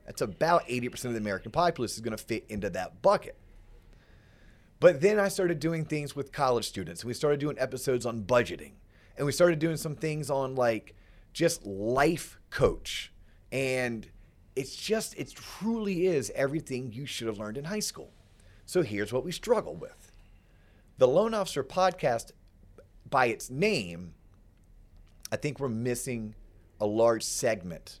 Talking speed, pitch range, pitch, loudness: 160 wpm, 105-160 Hz, 125 Hz, -29 LUFS